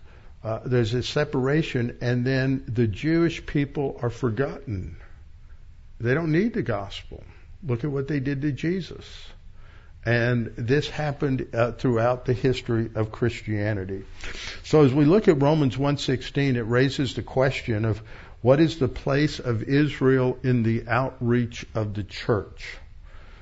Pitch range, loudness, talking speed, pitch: 105-140 Hz, -24 LUFS, 145 wpm, 120 Hz